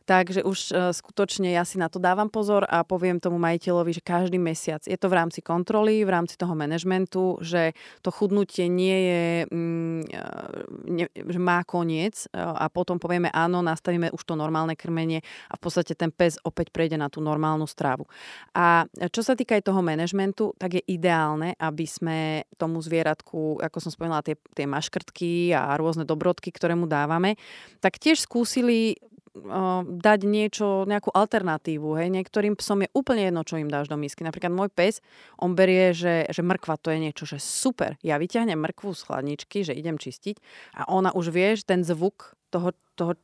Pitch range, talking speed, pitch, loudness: 165-190 Hz, 175 wpm, 175 Hz, -25 LUFS